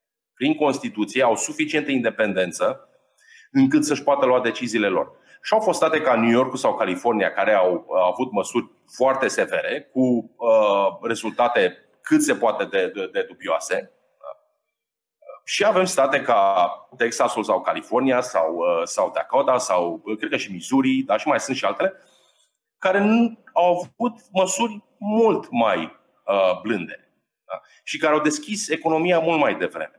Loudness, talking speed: -21 LUFS, 155 wpm